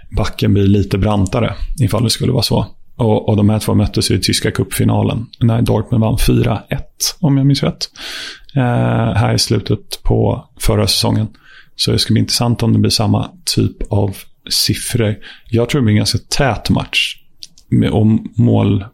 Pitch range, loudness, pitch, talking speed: 105-115 Hz, -15 LUFS, 110 Hz, 175 wpm